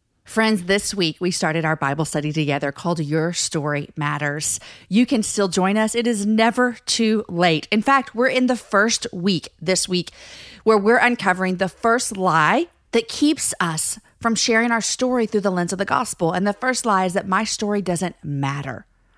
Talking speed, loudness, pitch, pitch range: 190 wpm, -20 LUFS, 195 Hz, 165-225 Hz